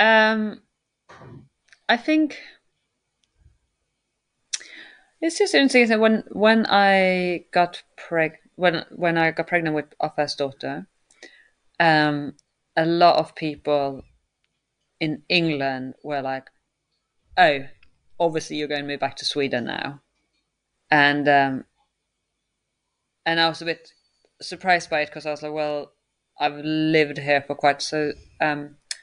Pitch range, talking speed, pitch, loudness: 145-175 Hz, 125 wpm, 155 Hz, -22 LUFS